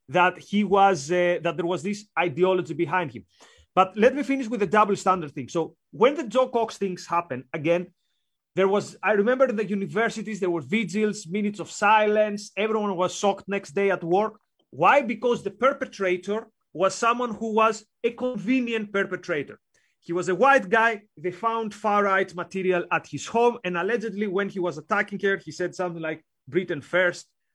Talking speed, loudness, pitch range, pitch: 185 wpm, -24 LUFS, 175-220 Hz, 195 Hz